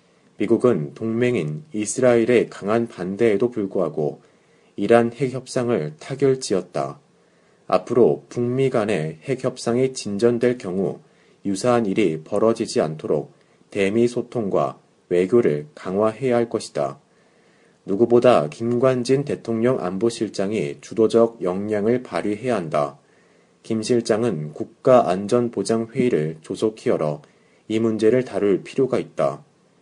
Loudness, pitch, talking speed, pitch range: -21 LUFS, 115 Hz, 265 characters per minute, 100-125 Hz